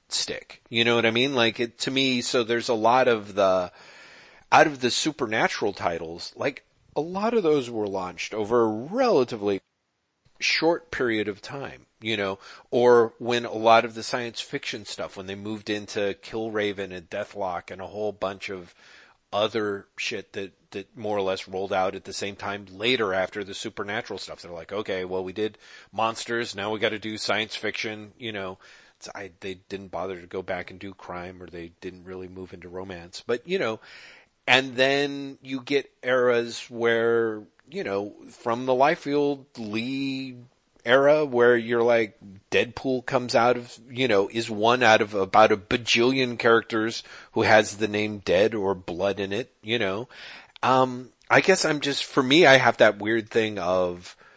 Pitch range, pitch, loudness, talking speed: 100-125 Hz, 110 Hz, -24 LUFS, 185 wpm